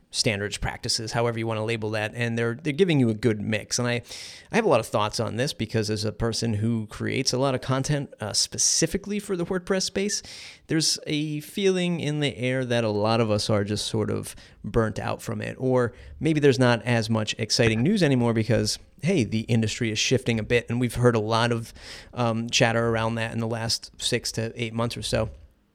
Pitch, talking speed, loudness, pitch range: 115 Hz, 225 wpm, -25 LUFS, 110-130 Hz